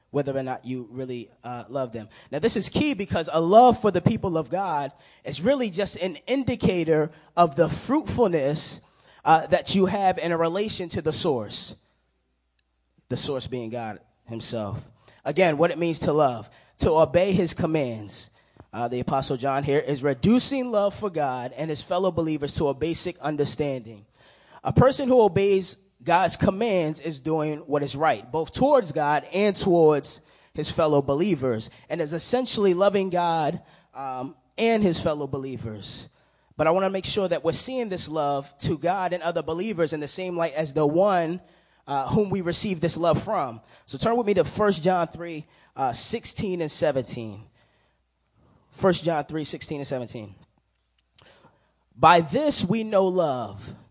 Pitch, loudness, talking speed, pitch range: 160 Hz, -24 LUFS, 170 wpm, 135-185 Hz